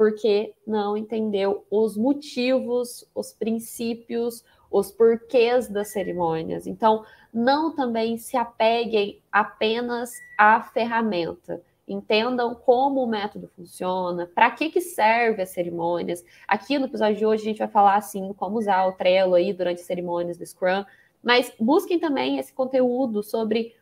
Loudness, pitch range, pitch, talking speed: -23 LUFS, 200-245 Hz, 225 Hz, 140 wpm